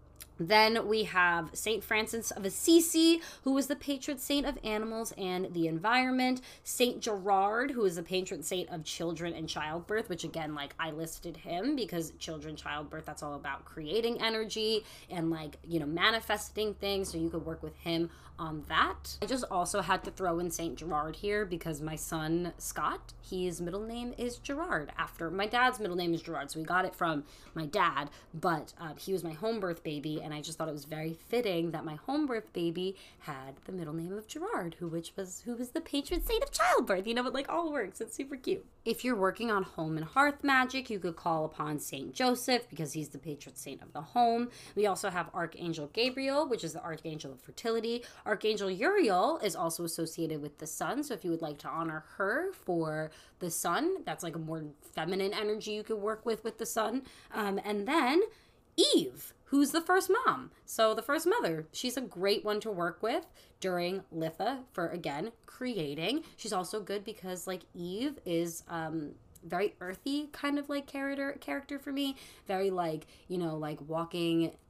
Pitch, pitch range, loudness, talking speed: 190 Hz, 165-240 Hz, -33 LUFS, 200 wpm